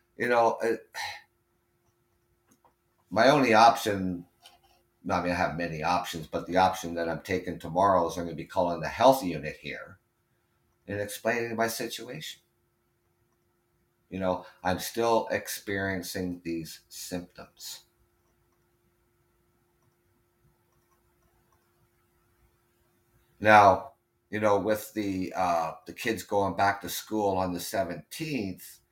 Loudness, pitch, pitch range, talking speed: -27 LUFS, 95 Hz, 90-115 Hz, 110 wpm